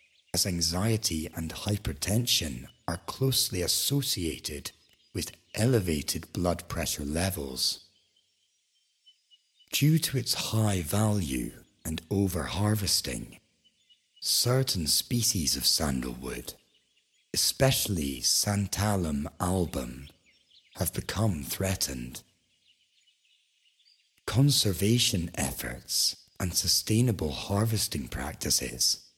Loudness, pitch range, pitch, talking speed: -28 LUFS, 80-110 Hz, 95 Hz, 70 wpm